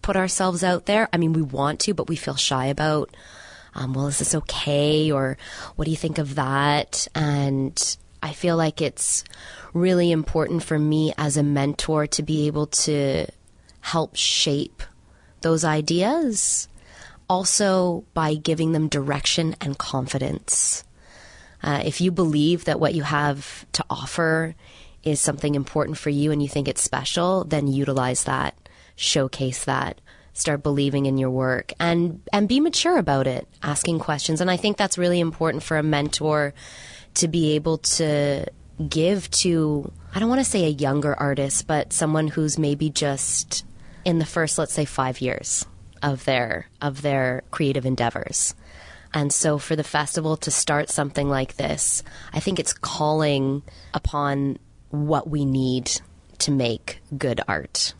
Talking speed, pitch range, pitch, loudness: 160 wpm, 140-160 Hz, 150 Hz, -23 LUFS